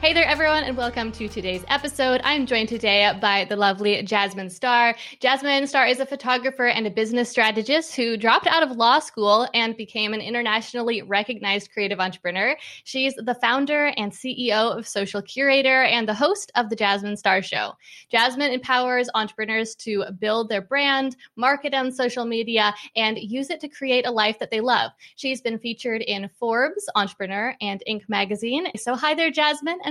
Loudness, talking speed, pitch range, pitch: -22 LUFS, 180 wpm, 210-265 Hz, 235 Hz